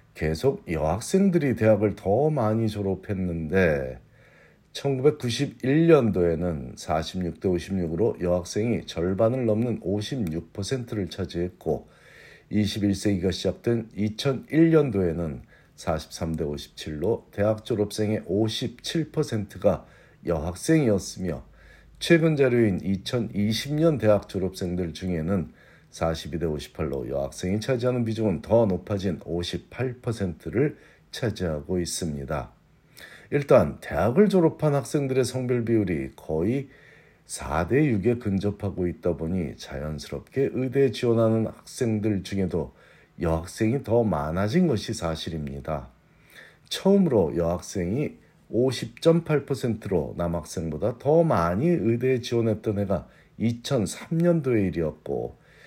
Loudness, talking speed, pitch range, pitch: -25 LUFS, 215 characters per minute, 85-125 Hz, 105 Hz